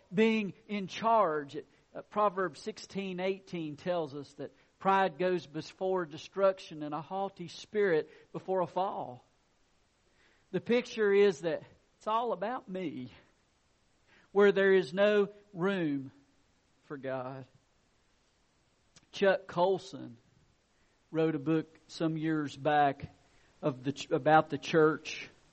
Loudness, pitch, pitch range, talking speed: -31 LUFS, 175 Hz, 150-195 Hz, 115 wpm